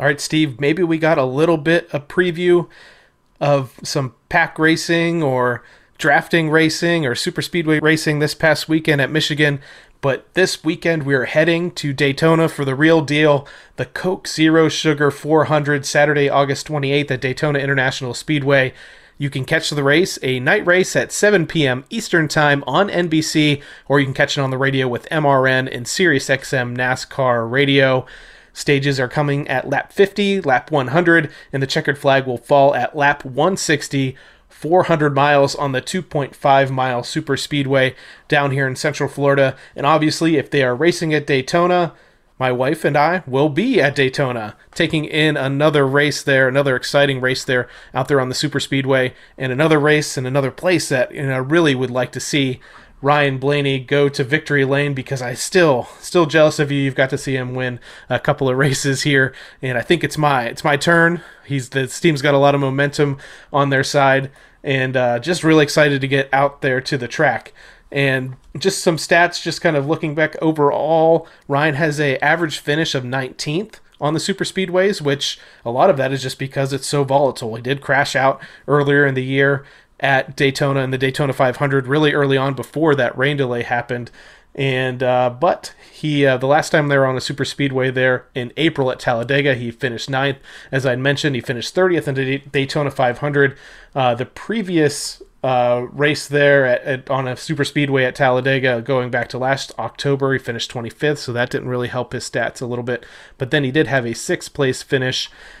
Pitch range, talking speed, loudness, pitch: 130-155 Hz, 190 wpm, -17 LUFS, 140 Hz